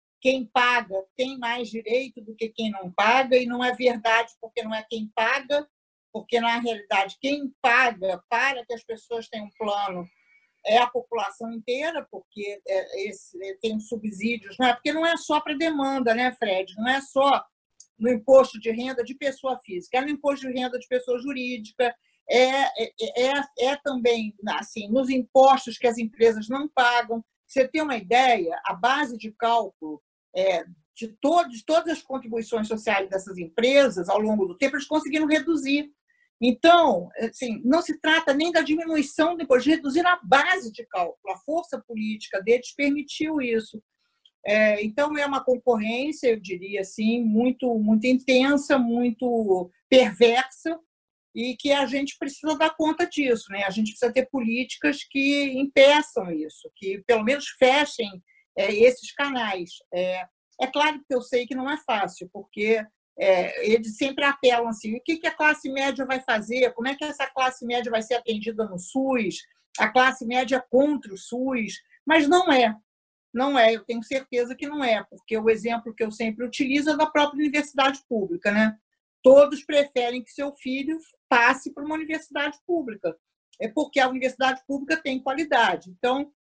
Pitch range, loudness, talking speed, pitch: 225-280 Hz, -24 LUFS, 170 wpm, 250 Hz